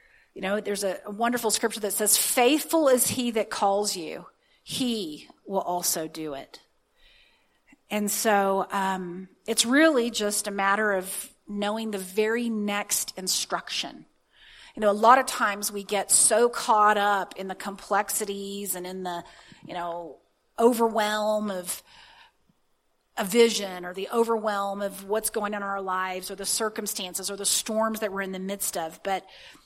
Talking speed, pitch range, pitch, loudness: 160 wpm, 195-220 Hz, 205 Hz, -25 LUFS